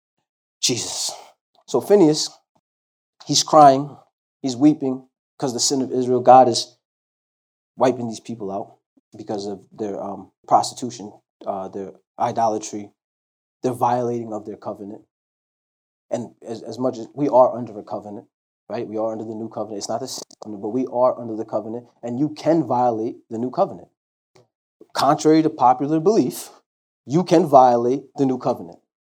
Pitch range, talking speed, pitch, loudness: 110-135 Hz, 155 wpm, 120 Hz, -20 LUFS